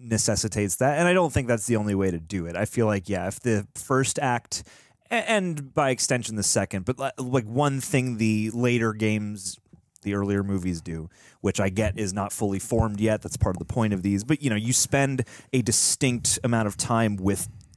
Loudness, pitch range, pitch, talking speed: -25 LUFS, 100-130 Hz, 110 Hz, 215 wpm